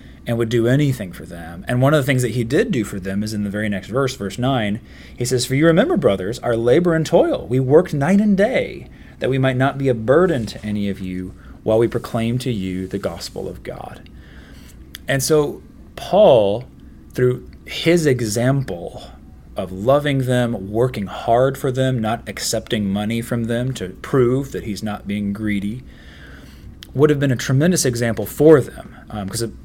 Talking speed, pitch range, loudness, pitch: 190 wpm, 100-130 Hz, -19 LUFS, 115 Hz